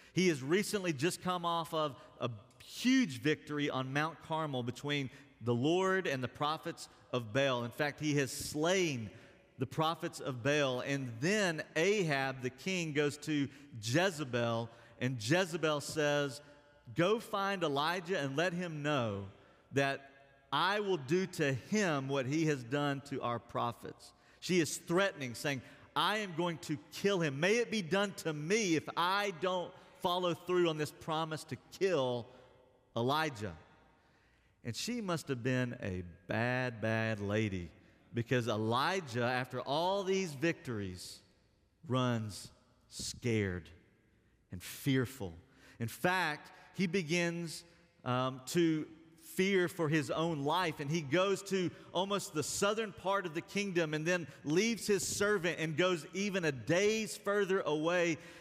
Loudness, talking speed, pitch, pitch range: -35 LUFS, 145 wpm, 150 Hz, 125-180 Hz